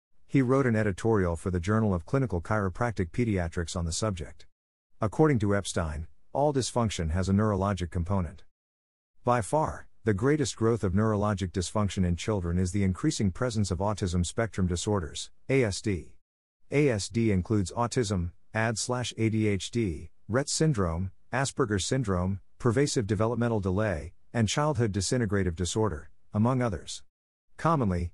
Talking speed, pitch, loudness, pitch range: 130 wpm, 105 Hz, -28 LUFS, 90-115 Hz